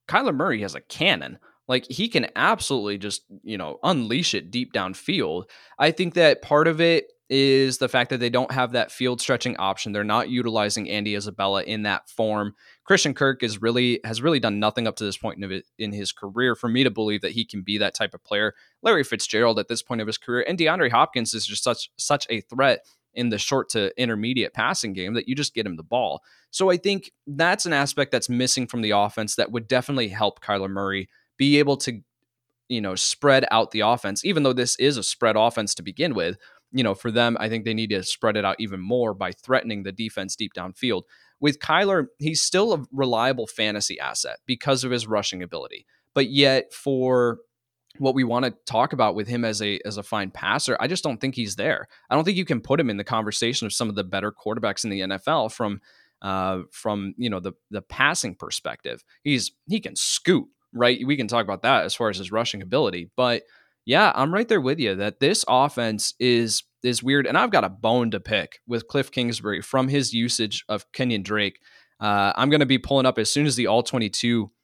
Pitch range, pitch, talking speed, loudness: 105-130 Hz, 120 Hz, 220 wpm, -23 LUFS